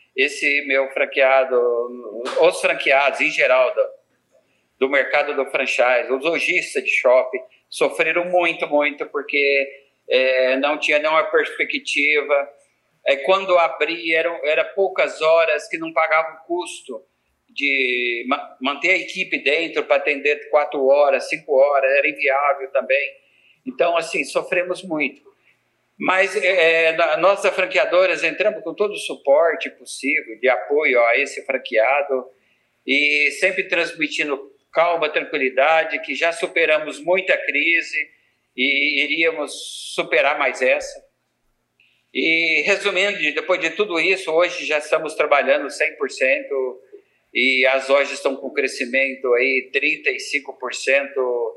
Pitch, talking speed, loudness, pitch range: 160 Hz, 125 wpm, -19 LUFS, 140-185 Hz